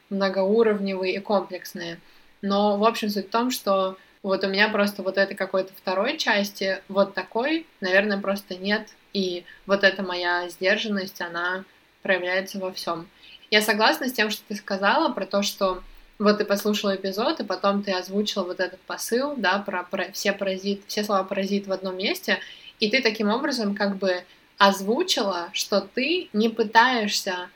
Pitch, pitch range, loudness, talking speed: 200 Hz, 190-215 Hz, -24 LUFS, 165 wpm